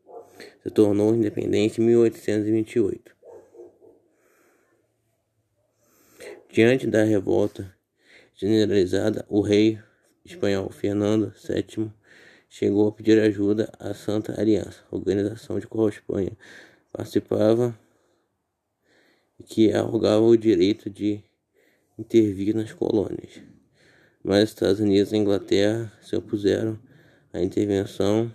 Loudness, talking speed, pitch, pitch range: -23 LUFS, 95 wpm, 110 Hz, 105-115 Hz